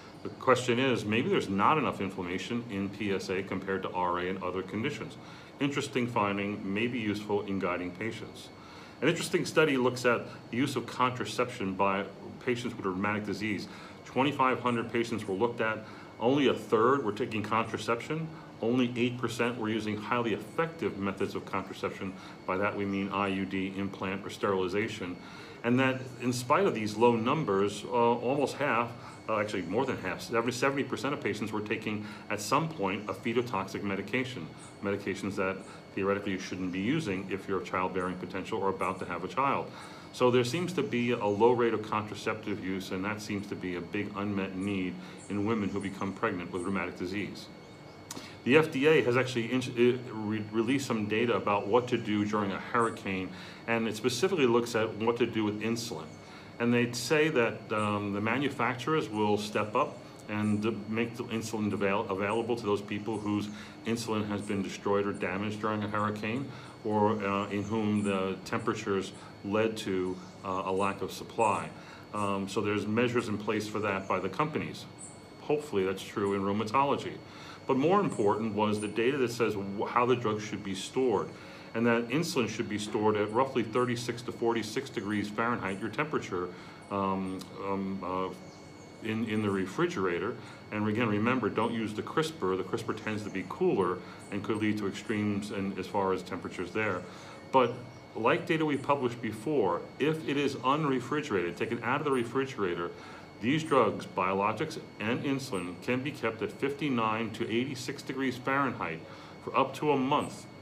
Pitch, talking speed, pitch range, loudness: 110 Hz, 170 wpm, 100-120 Hz, -31 LUFS